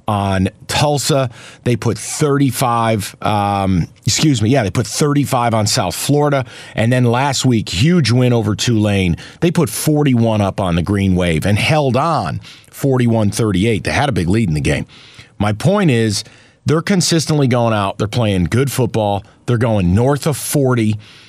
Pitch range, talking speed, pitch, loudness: 105-140 Hz, 170 wpm, 120 Hz, -15 LUFS